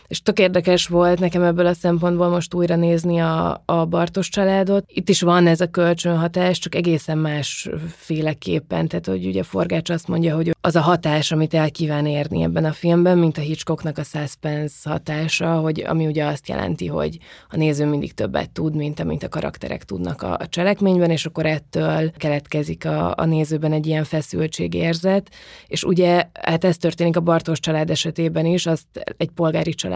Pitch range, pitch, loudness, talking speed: 155-175 Hz, 165 Hz, -20 LUFS, 185 wpm